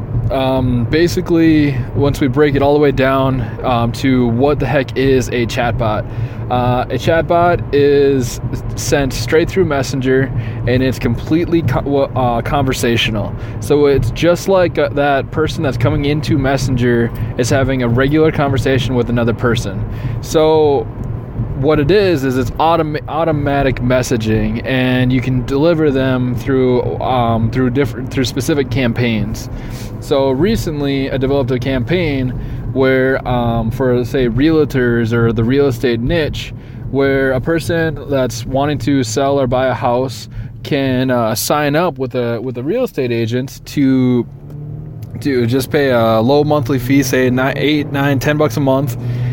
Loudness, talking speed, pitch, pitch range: -15 LUFS, 155 wpm, 130 Hz, 120-140 Hz